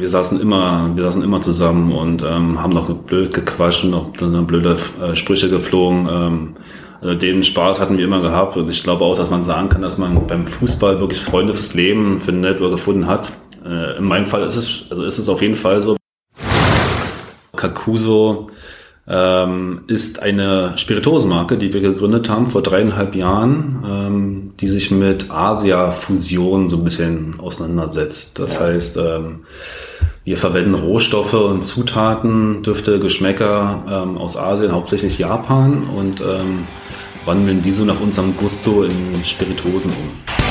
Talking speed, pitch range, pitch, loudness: 160 wpm, 90-100 Hz, 95 Hz, -16 LUFS